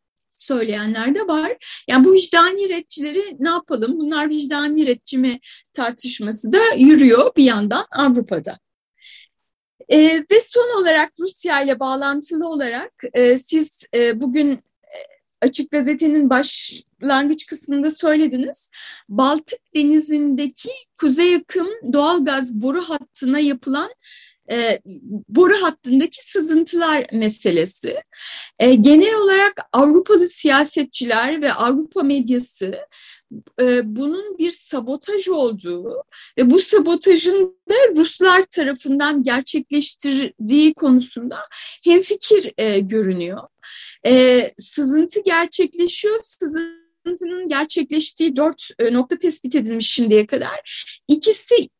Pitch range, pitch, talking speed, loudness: 255-345 Hz, 295 Hz, 100 wpm, -17 LUFS